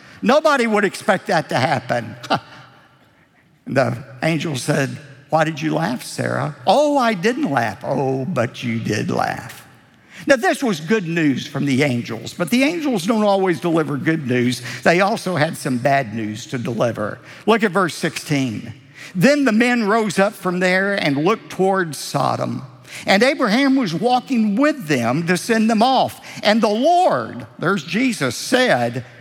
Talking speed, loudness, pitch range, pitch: 160 wpm, -18 LUFS, 140-230 Hz, 180 Hz